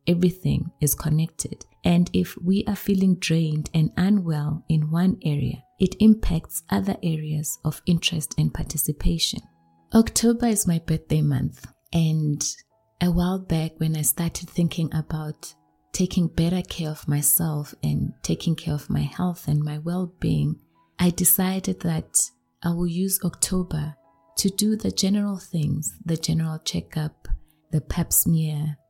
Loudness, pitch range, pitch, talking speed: -24 LUFS, 150-180 Hz, 160 Hz, 145 wpm